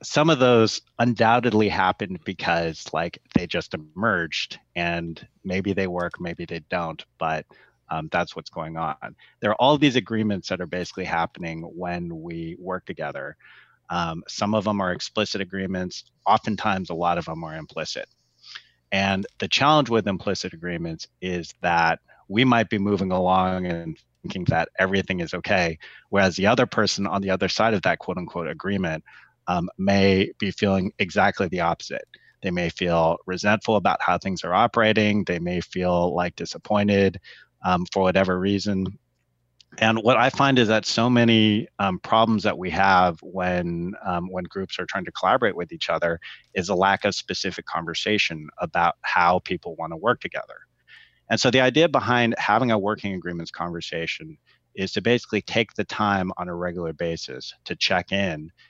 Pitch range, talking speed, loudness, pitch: 90-110 Hz, 170 wpm, -23 LUFS, 95 Hz